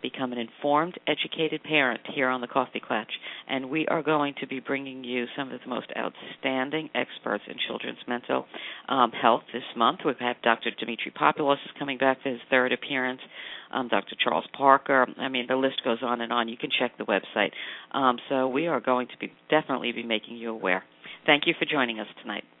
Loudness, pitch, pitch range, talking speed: -27 LUFS, 130 Hz, 120-140 Hz, 205 wpm